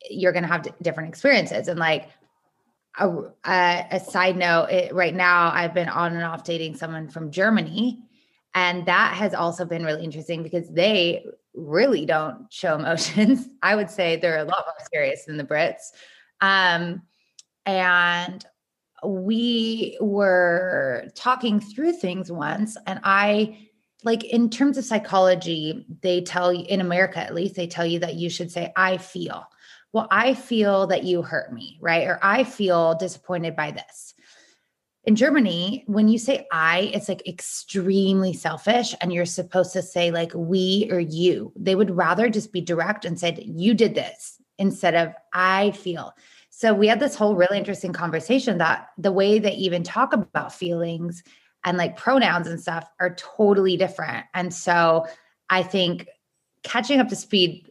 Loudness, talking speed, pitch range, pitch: -22 LUFS, 165 wpm, 170-210 Hz, 185 Hz